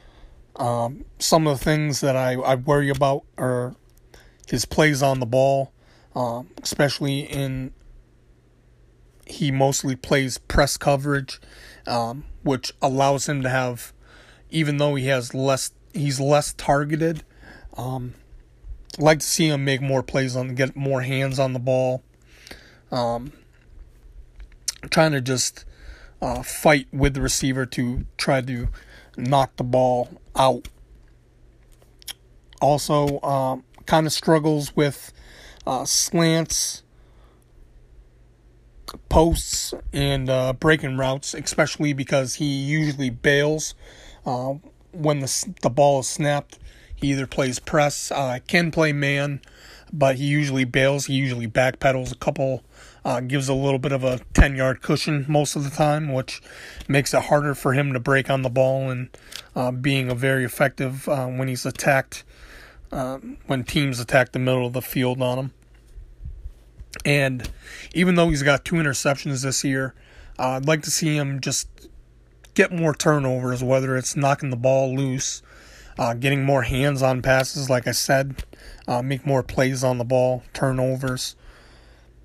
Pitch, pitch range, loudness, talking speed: 135 Hz, 125-145 Hz, -22 LUFS, 145 wpm